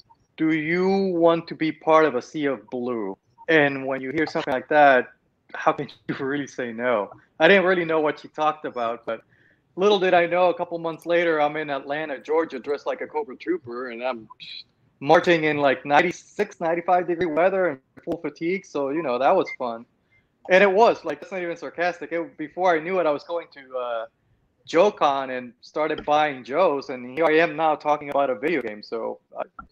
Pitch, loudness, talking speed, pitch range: 155 Hz, -23 LUFS, 210 wpm, 135-175 Hz